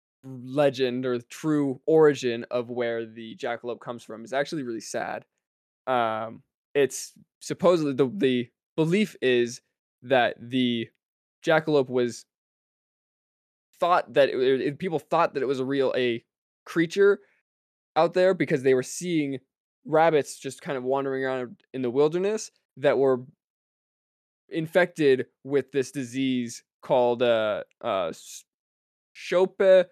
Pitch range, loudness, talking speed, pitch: 125-160 Hz, -25 LUFS, 130 wpm, 135 Hz